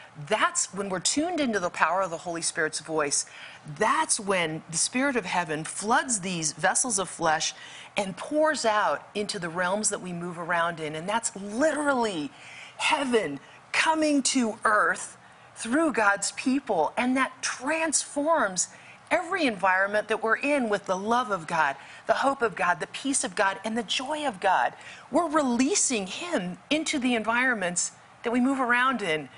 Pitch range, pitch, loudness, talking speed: 180-275 Hz, 220 Hz, -26 LUFS, 165 wpm